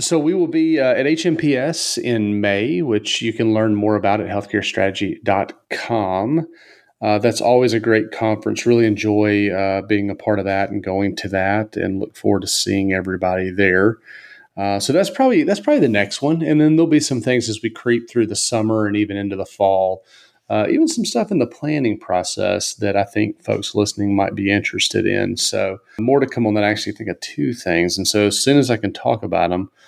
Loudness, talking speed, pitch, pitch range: -18 LUFS, 215 wpm, 105 Hz, 100-120 Hz